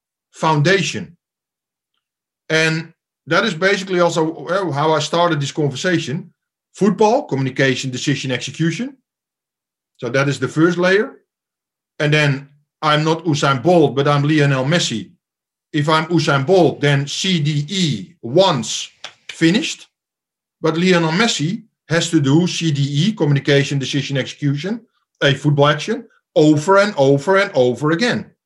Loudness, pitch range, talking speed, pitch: -17 LUFS, 140-180 Hz, 120 wpm, 160 Hz